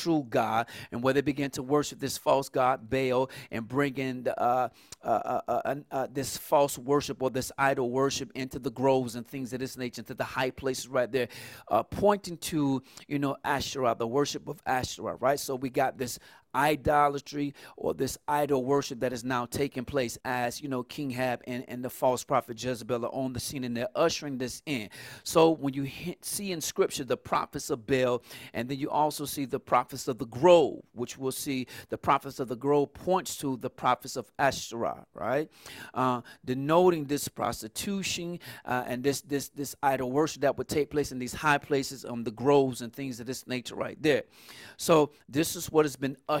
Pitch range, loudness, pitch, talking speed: 125-145 Hz, -30 LUFS, 135 Hz, 205 wpm